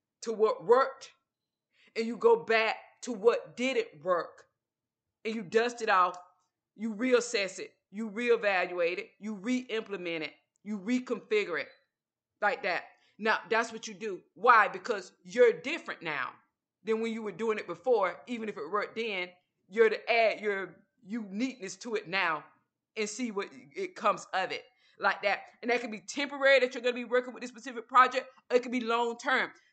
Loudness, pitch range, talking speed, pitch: -30 LUFS, 215-255 Hz, 180 wpm, 230 Hz